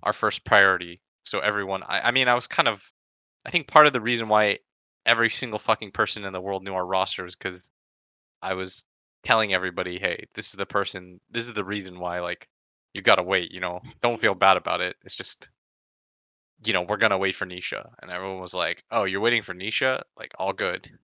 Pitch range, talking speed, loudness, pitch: 90-115 Hz, 220 wpm, -24 LUFS, 100 Hz